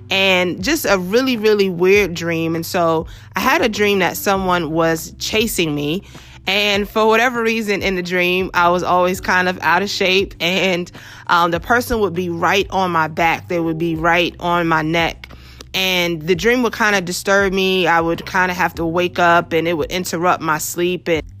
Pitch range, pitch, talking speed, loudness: 165-195 Hz, 180 Hz, 205 wpm, -16 LUFS